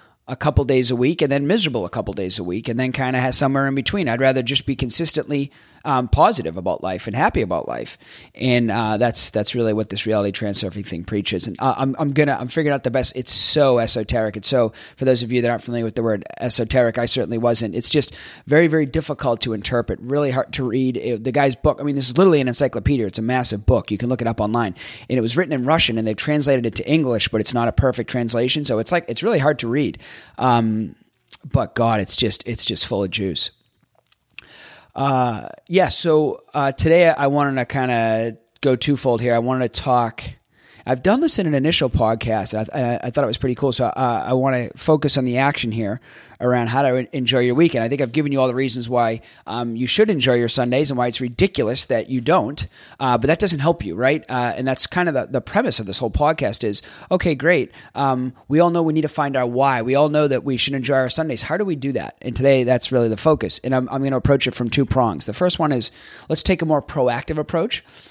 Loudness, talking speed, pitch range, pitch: -19 LUFS, 250 wpm, 115-140 Hz, 125 Hz